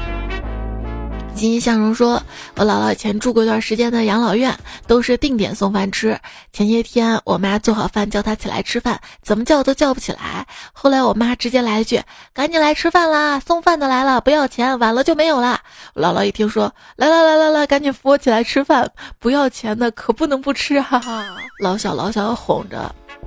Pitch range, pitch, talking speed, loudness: 215-275 Hz, 235 Hz, 290 characters per minute, -17 LUFS